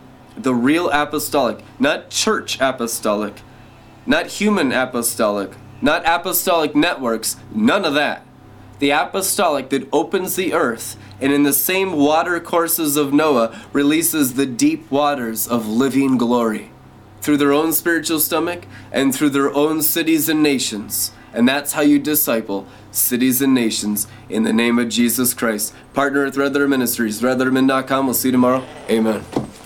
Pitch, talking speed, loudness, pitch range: 135 Hz, 150 wpm, -18 LUFS, 120-150 Hz